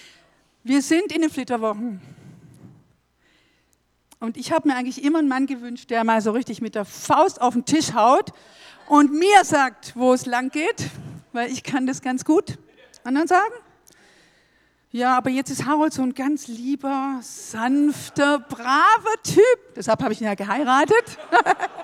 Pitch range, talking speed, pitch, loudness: 235-305 Hz, 160 wpm, 265 Hz, -20 LUFS